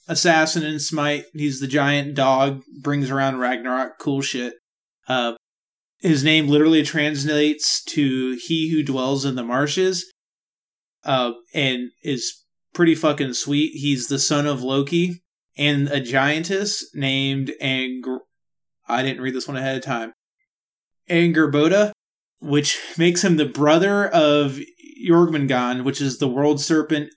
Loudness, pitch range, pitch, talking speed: -20 LUFS, 135-155 Hz, 145 Hz, 135 wpm